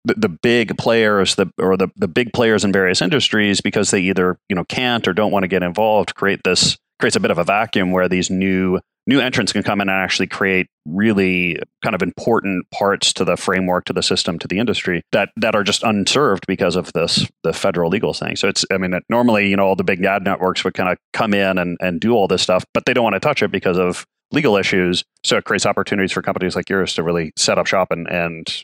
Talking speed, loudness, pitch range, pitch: 250 wpm, -17 LUFS, 90-105 Hz, 95 Hz